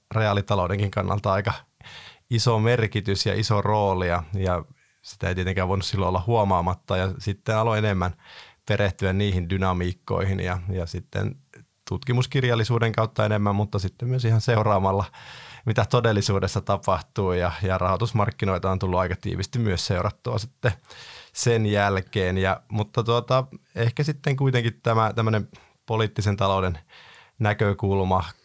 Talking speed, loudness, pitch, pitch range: 125 wpm, -24 LUFS, 100 Hz, 95-115 Hz